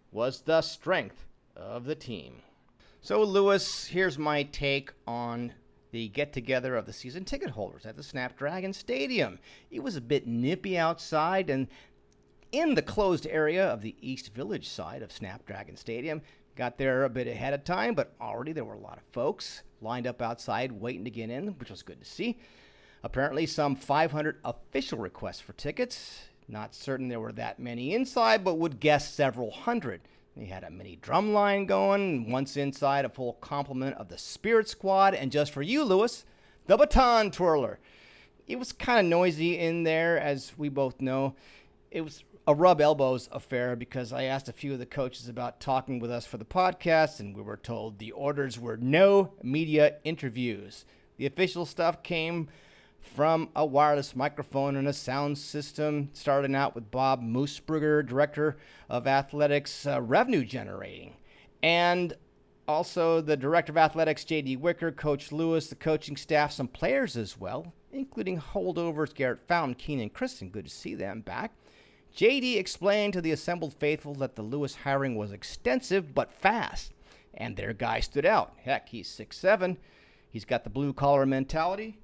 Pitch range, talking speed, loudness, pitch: 125-165 Hz, 170 wpm, -29 LUFS, 145 Hz